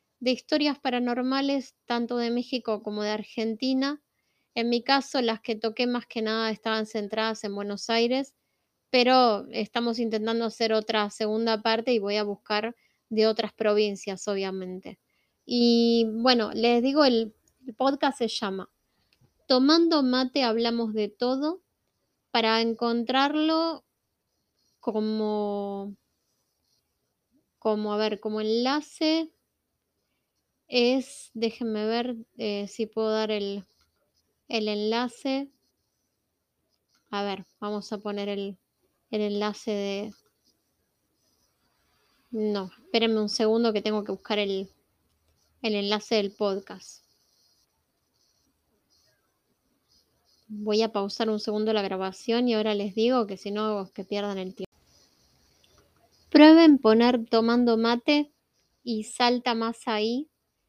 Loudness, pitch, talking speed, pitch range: -26 LUFS, 225 Hz, 115 wpm, 210-245 Hz